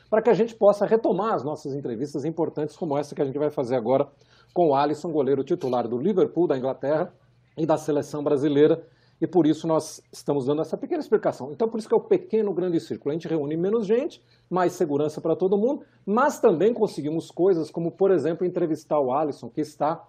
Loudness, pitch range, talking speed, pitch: -24 LUFS, 145-200 Hz, 210 wpm, 160 Hz